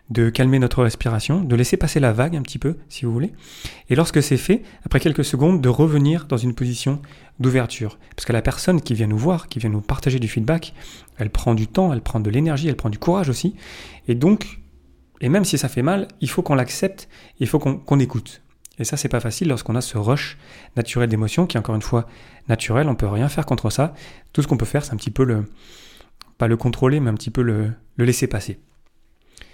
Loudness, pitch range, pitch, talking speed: -21 LUFS, 115-150 Hz, 130 Hz, 235 wpm